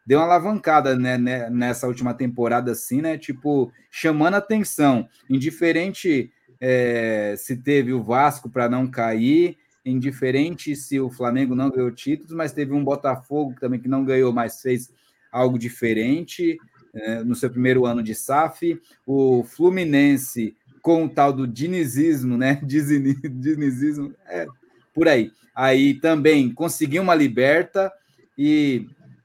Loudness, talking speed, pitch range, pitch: -21 LUFS, 135 wpm, 125-155 Hz, 135 Hz